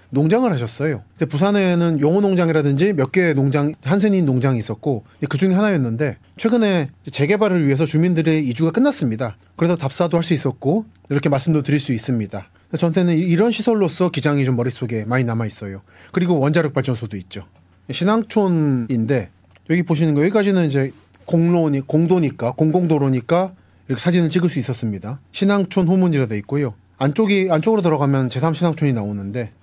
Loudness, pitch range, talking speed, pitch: -19 LUFS, 125-175 Hz, 400 characters per minute, 150 Hz